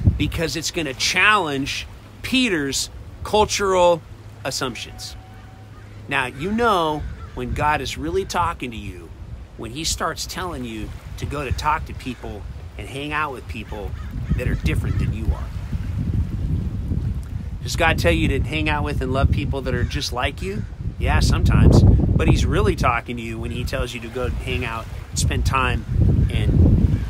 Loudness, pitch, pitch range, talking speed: -21 LUFS, 110 Hz, 100-130 Hz, 165 wpm